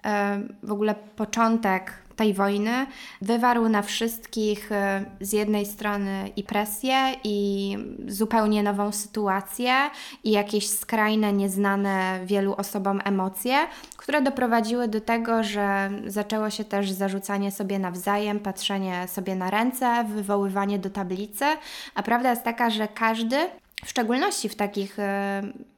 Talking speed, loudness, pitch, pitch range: 120 wpm, -25 LUFS, 210 Hz, 200-235 Hz